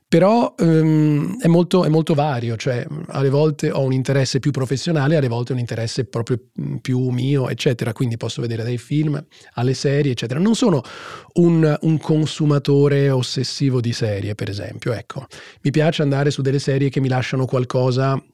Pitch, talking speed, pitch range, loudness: 140 Hz, 170 wpm, 125-155 Hz, -19 LUFS